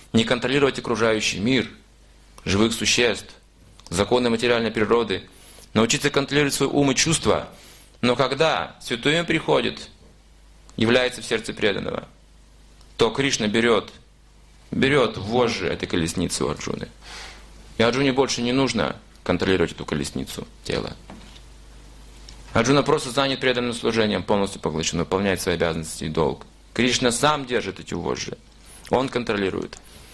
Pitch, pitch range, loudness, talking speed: 115 Hz, 95-130 Hz, -22 LUFS, 120 wpm